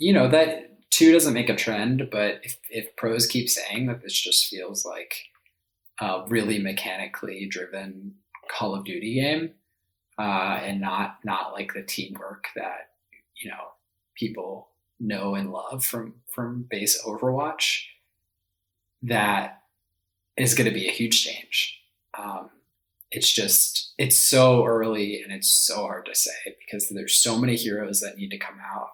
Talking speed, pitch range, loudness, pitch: 160 wpm, 95-120 Hz, -23 LUFS, 105 Hz